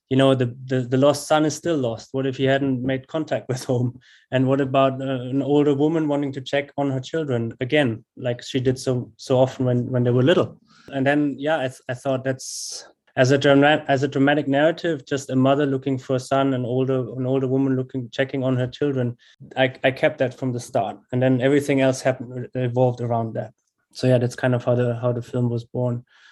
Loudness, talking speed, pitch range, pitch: -22 LUFS, 235 wpm, 125-140 Hz, 130 Hz